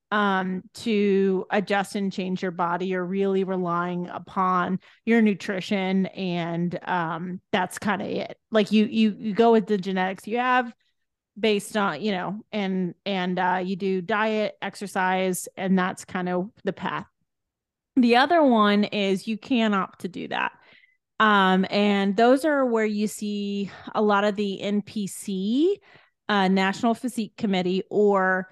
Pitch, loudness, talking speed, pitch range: 200 Hz, -24 LUFS, 155 wpm, 185-215 Hz